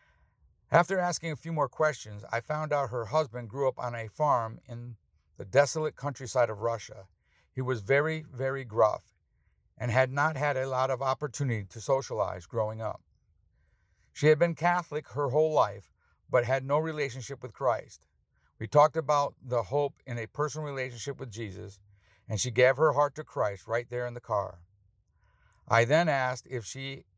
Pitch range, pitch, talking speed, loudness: 115-145 Hz, 130 Hz, 175 wpm, -29 LUFS